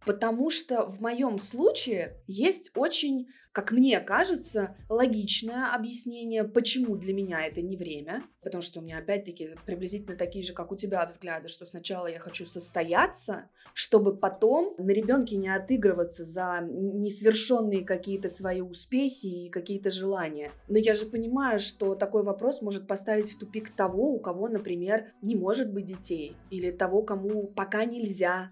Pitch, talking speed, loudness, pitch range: 200 Hz, 155 wpm, -29 LUFS, 185-230 Hz